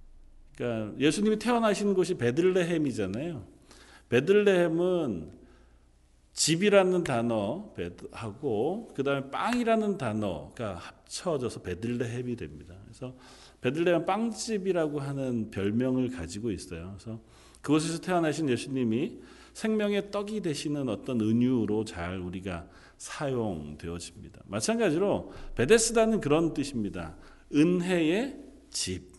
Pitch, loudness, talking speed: 130 Hz, -29 LUFS, 290 characters per minute